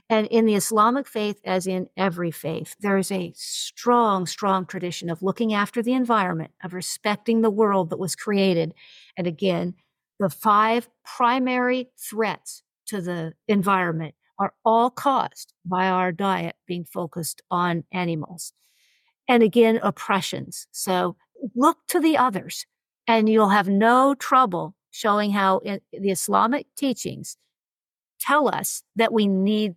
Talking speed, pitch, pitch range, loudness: 140 wpm, 200 Hz, 180-230 Hz, -23 LUFS